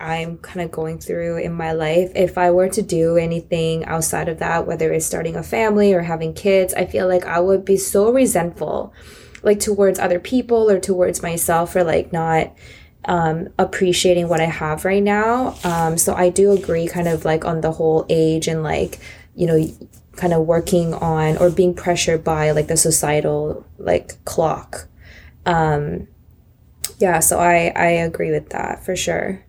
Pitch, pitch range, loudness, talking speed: 170 Hz, 160-185 Hz, -18 LUFS, 180 wpm